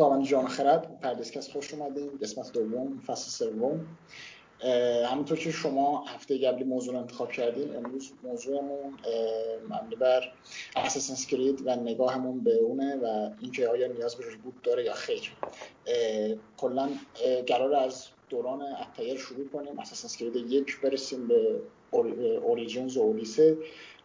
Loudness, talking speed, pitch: -30 LUFS, 130 wpm, 140 Hz